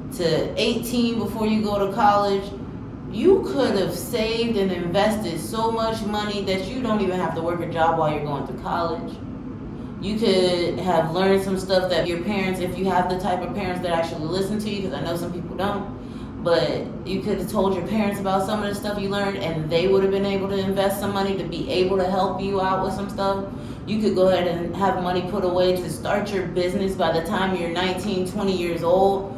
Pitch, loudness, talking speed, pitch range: 190 Hz, -23 LUFS, 230 wpm, 180-200 Hz